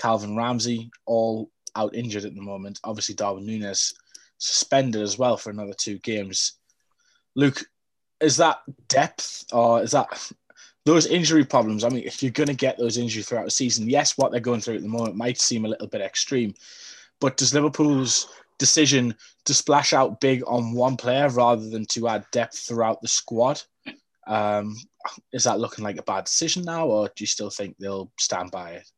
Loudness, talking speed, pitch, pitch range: -23 LUFS, 190 wpm, 120 Hz, 105-135 Hz